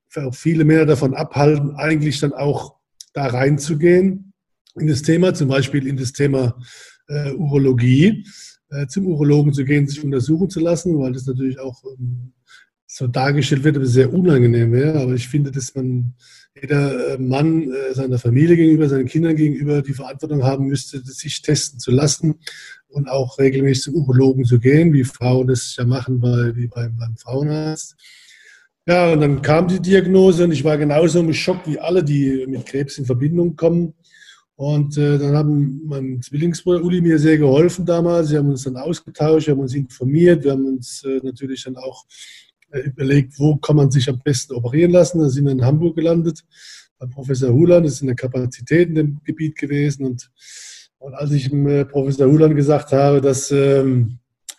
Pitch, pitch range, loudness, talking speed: 145 Hz, 130-155 Hz, -17 LUFS, 185 wpm